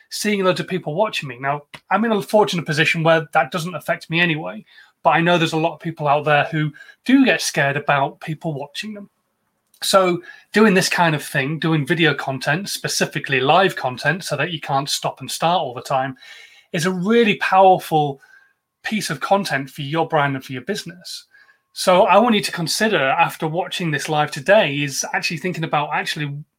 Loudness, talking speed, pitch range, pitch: -19 LUFS, 200 wpm, 150-190 Hz, 165 Hz